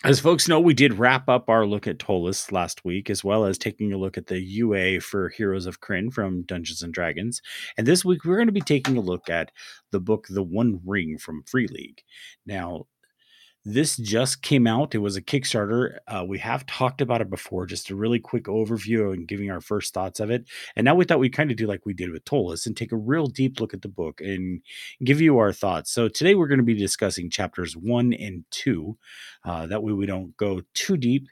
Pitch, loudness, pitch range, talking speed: 110 Hz, -24 LUFS, 95-130 Hz, 235 wpm